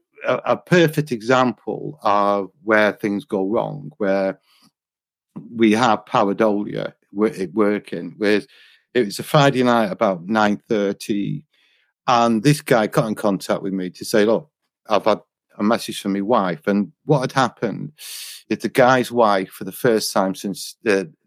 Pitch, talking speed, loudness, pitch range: 110 Hz, 150 wpm, -20 LUFS, 100-125 Hz